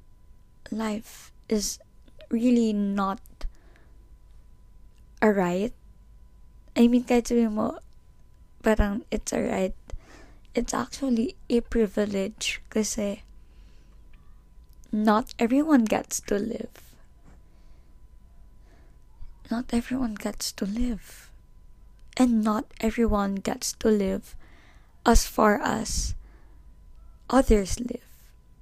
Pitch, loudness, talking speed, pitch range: 225 Hz, -26 LUFS, 80 wpm, 210-240 Hz